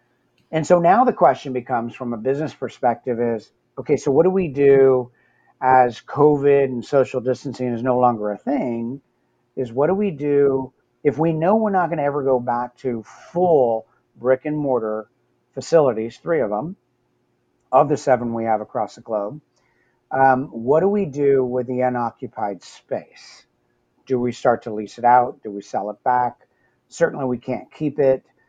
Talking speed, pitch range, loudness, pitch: 180 wpm, 115-140 Hz, -20 LUFS, 125 Hz